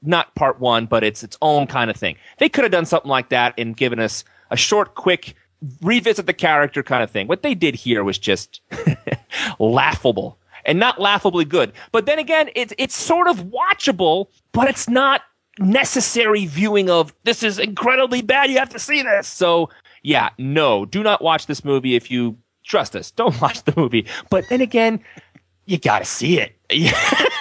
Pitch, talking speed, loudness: 185 Hz, 190 wpm, -18 LUFS